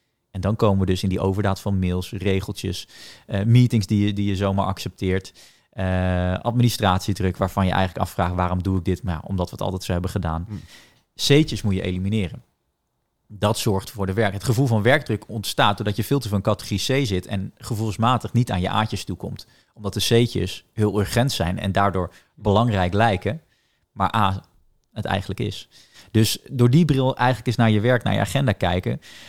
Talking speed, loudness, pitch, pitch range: 195 wpm, -22 LUFS, 100 Hz, 95-115 Hz